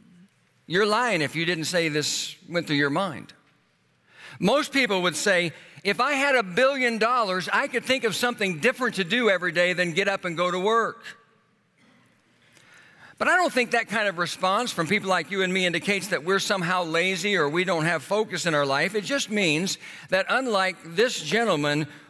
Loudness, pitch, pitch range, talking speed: -24 LUFS, 190 Hz, 175-220 Hz, 195 wpm